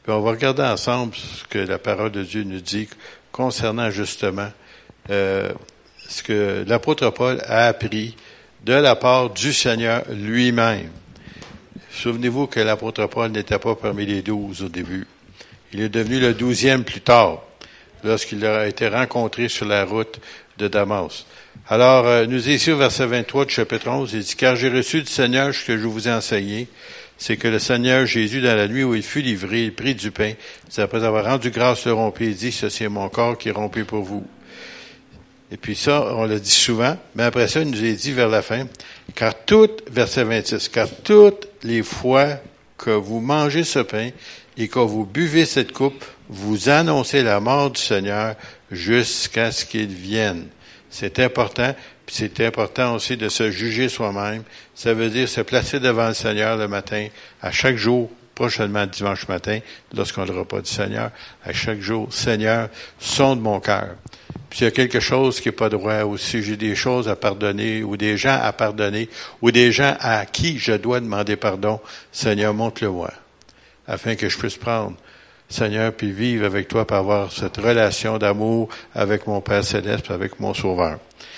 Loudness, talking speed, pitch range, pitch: -20 LUFS, 185 wpm, 105-125 Hz, 115 Hz